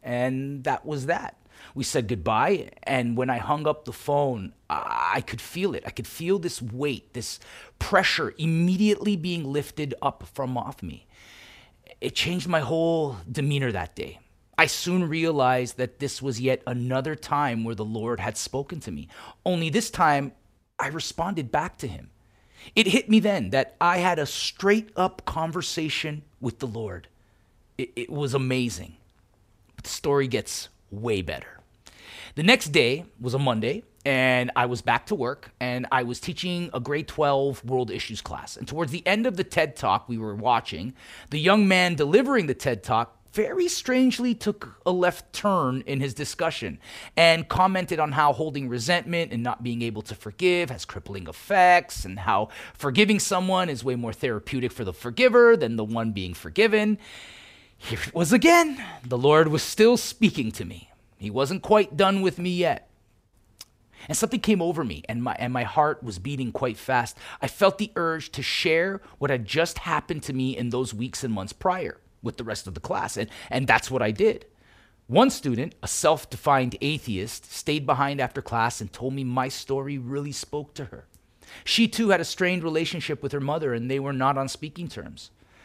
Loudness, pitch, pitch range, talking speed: -25 LUFS, 140 Hz, 120-170 Hz, 185 wpm